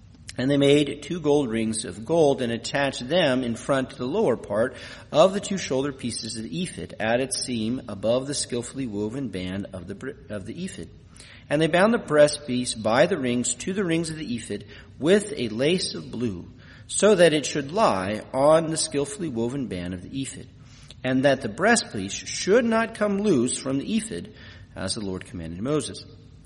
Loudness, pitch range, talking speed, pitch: -24 LUFS, 110-150 Hz, 200 wpm, 130 Hz